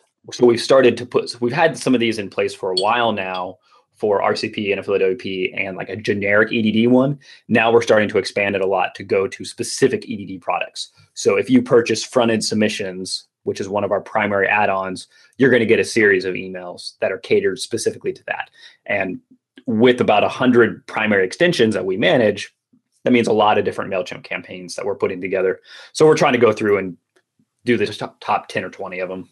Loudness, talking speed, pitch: -18 LUFS, 215 wpm, 120 Hz